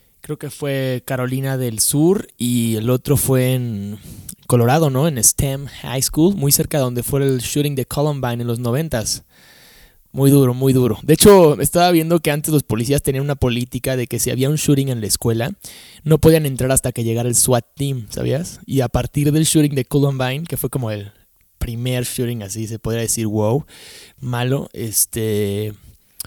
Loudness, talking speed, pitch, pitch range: -17 LUFS, 190 wpm, 130 Hz, 120-145 Hz